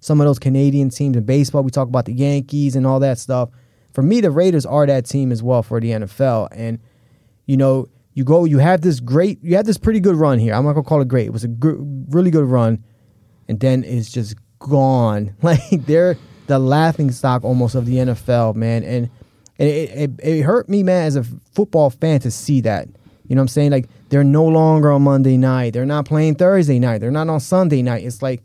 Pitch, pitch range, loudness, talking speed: 135 Hz, 125-150 Hz, -16 LUFS, 235 wpm